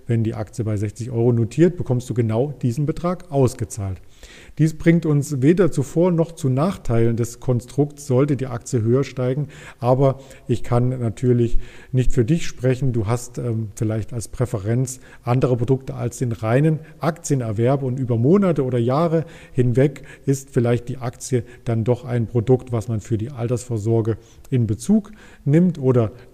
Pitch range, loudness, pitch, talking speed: 115-140 Hz, -21 LUFS, 125 Hz, 165 wpm